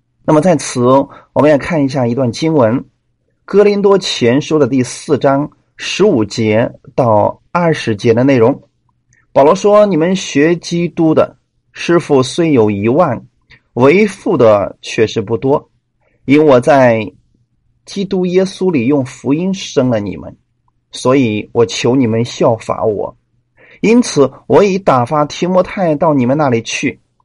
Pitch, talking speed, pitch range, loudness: 140 Hz, 205 characters per minute, 120-170 Hz, -12 LUFS